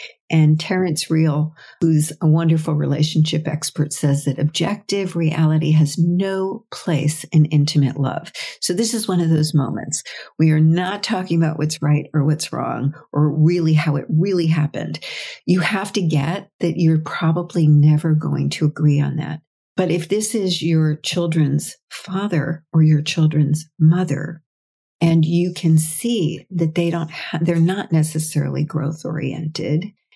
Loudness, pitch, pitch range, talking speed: -19 LUFS, 160 Hz, 150-175 Hz, 155 wpm